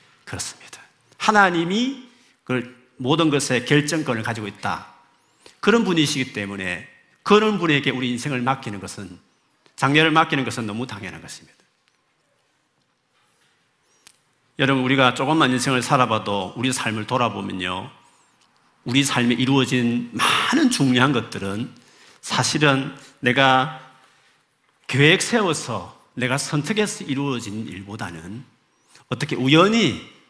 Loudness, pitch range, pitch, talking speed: -20 LUFS, 115-150 Hz, 130 Hz, 265 characters per minute